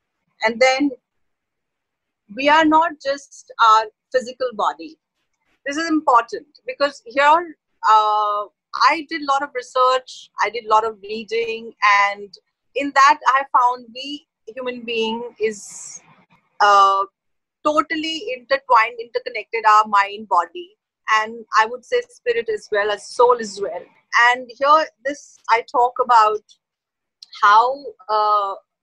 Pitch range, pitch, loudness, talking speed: 215-300 Hz, 250 Hz, -18 LUFS, 130 wpm